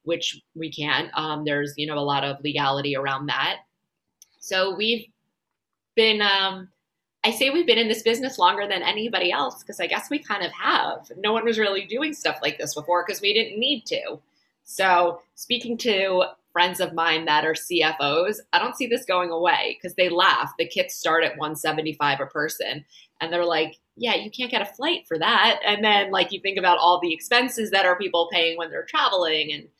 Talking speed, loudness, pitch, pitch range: 205 wpm, -22 LUFS, 180 Hz, 160-215 Hz